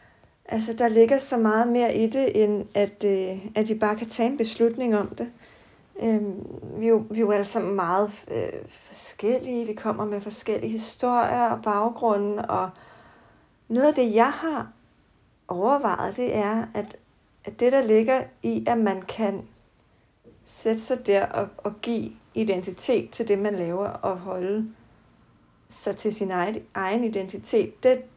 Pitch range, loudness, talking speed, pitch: 205-235 Hz, -25 LUFS, 160 wpm, 220 Hz